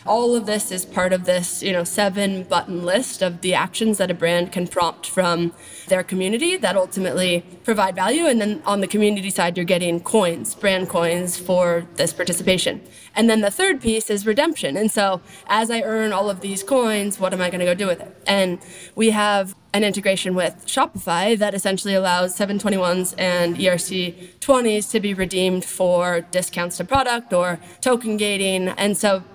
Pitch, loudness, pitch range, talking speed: 190 Hz, -20 LUFS, 180-210 Hz, 185 wpm